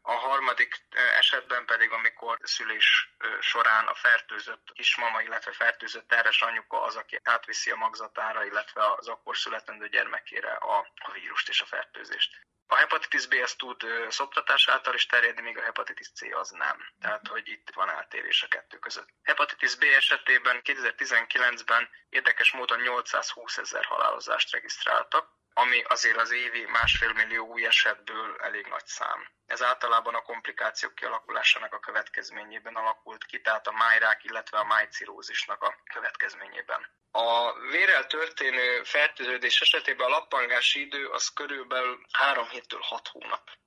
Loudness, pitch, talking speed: -26 LUFS, 395 Hz, 145 wpm